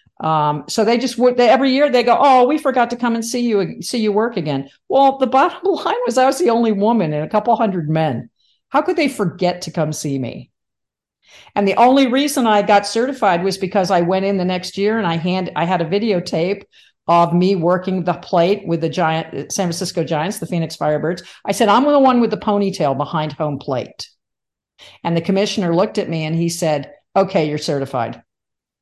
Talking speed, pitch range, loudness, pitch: 215 wpm, 165-230 Hz, -17 LUFS, 190 Hz